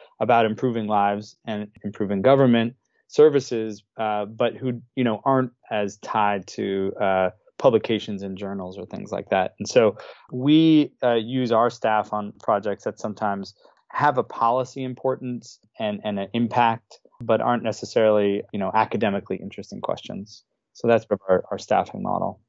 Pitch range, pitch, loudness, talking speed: 105-125 Hz, 110 Hz, -23 LUFS, 150 wpm